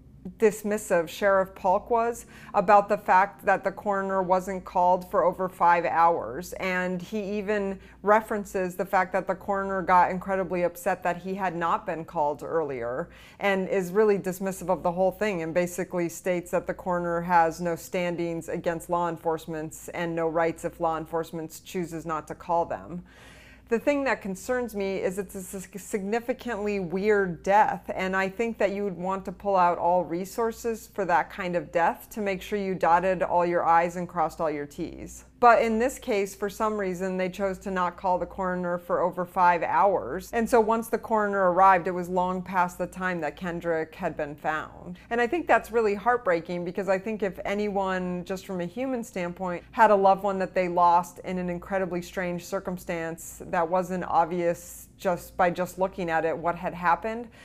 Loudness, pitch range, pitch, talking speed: -26 LUFS, 175-200 Hz, 185 Hz, 190 wpm